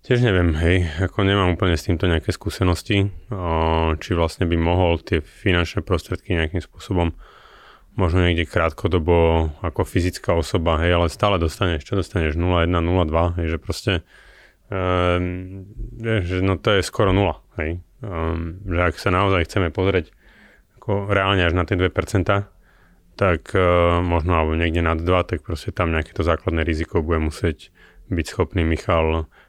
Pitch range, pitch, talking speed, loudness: 85-95 Hz, 90 Hz, 155 wpm, -21 LUFS